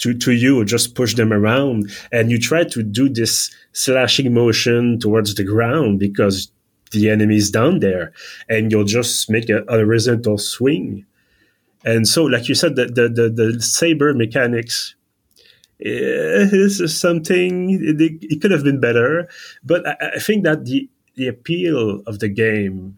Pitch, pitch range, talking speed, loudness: 120 Hz, 110-145 Hz, 165 wpm, -17 LUFS